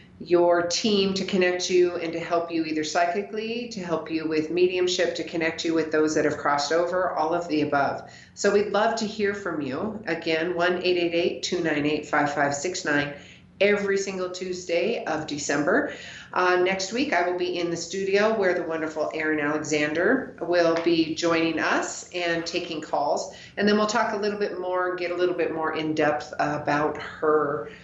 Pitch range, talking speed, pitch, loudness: 155-185 Hz, 180 wpm, 170 Hz, -25 LUFS